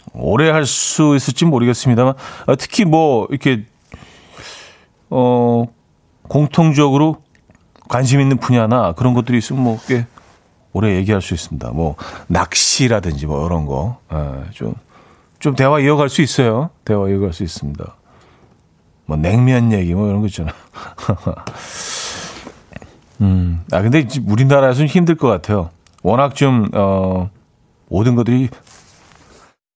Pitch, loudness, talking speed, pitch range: 120 Hz, -15 LUFS, 250 characters per minute, 95-140 Hz